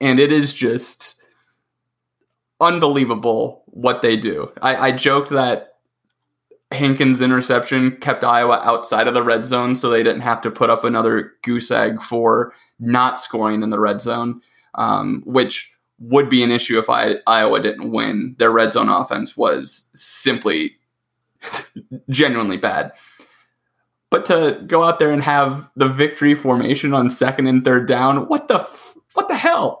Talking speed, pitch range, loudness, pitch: 155 wpm, 120-140 Hz, -17 LUFS, 130 Hz